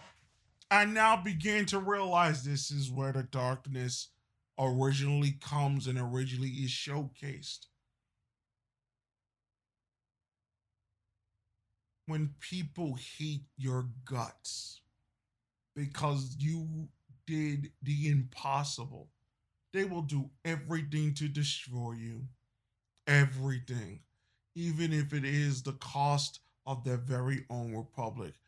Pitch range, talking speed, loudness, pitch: 115-145 Hz, 95 wpm, -34 LUFS, 135 Hz